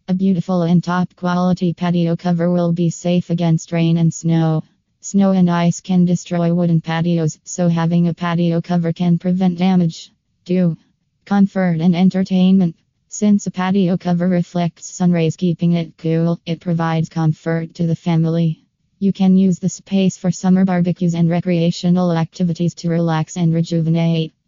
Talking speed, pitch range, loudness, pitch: 155 wpm, 165-180 Hz, -17 LUFS, 175 Hz